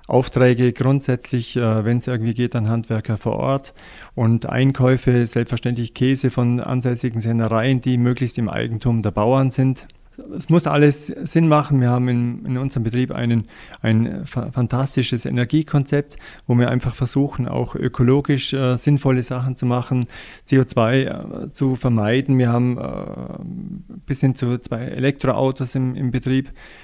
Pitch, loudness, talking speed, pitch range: 125 Hz, -20 LUFS, 140 wpm, 120-135 Hz